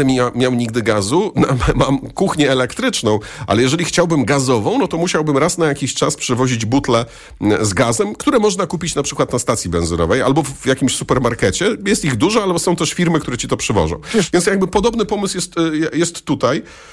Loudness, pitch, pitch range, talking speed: -16 LUFS, 145 Hz, 125-175 Hz, 180 wpm